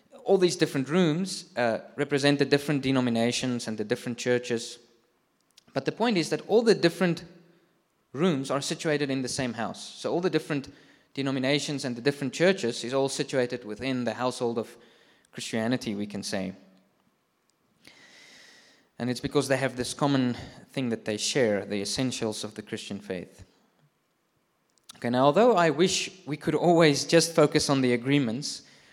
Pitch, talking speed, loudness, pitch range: 135 Hz, 160 wpm, -27 LUFS, 120-155 Hz